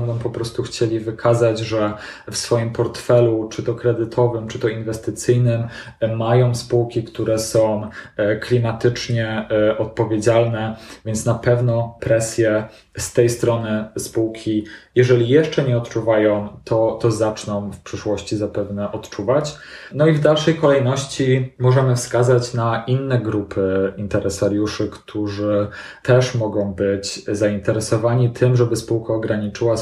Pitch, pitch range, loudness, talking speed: 115 Hz, 110-120 Hz, -19 LUFS, 120 wpm